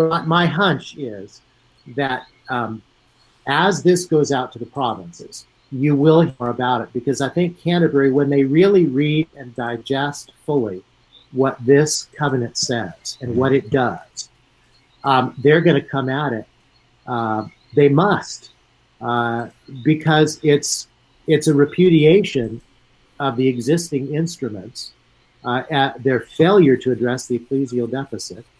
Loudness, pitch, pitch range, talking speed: -18 LUFS, 130 Hz, 120-150 Hz, 140 wpm